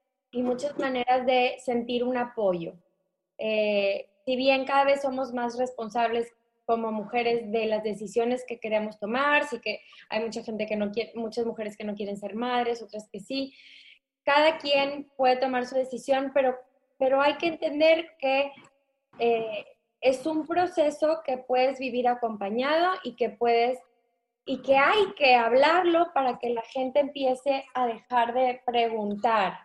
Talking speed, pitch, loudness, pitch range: 160 wpm, 250 Hz, -26 LUFS, 230-275 Hz